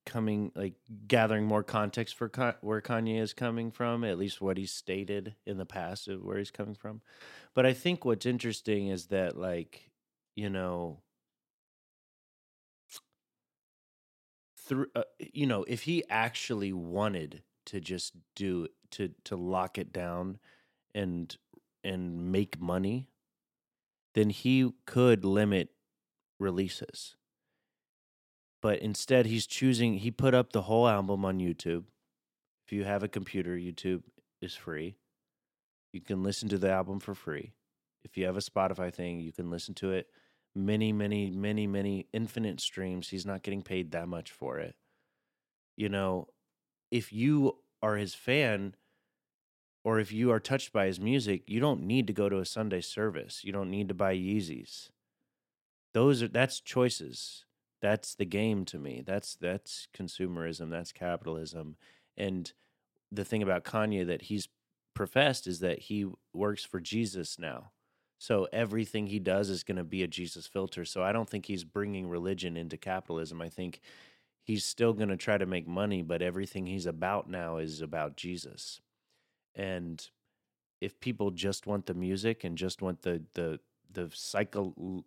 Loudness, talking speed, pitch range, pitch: -33 LUFS, 160 wpm, 90-110 Hz, 100 Hz